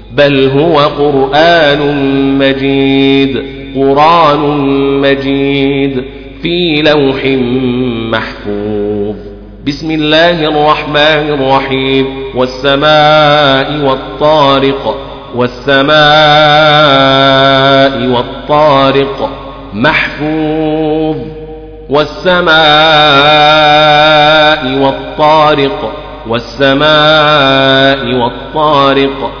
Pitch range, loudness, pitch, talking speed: 135-150 Hz, -8 LUFS, 140 Hz, 45 wpm